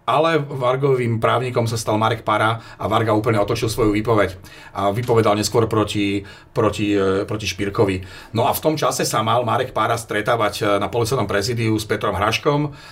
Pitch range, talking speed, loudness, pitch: 105-120 Hz, 165 wpm, -20 LUFS, 110 Hz